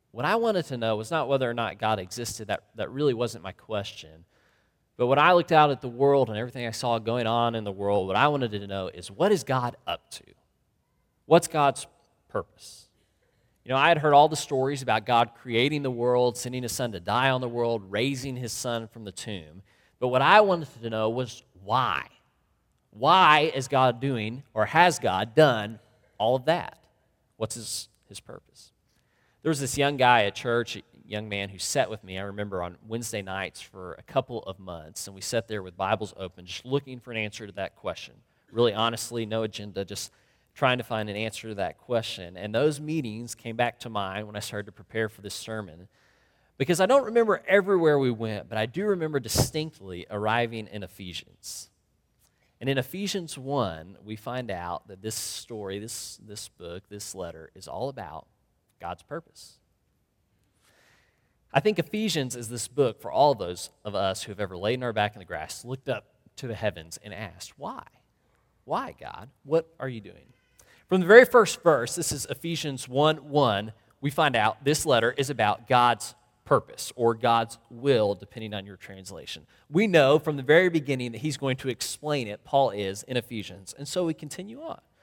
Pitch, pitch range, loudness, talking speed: 115 Hz, 105-140 Hz, -26 LUFS, 200 wpm